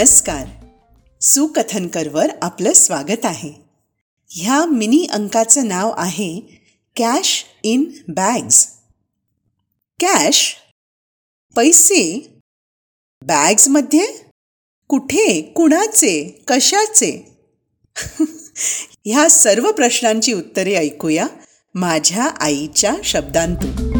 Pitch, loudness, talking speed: 240 Hz, -14 LUFS, 70 wpm